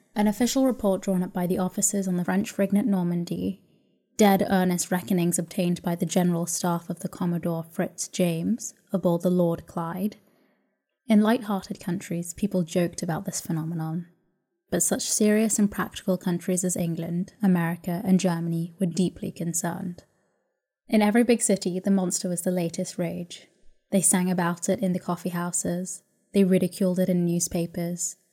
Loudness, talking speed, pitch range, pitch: -25 LUFS, 160 wpm, 175-195 Hz, 180 Hz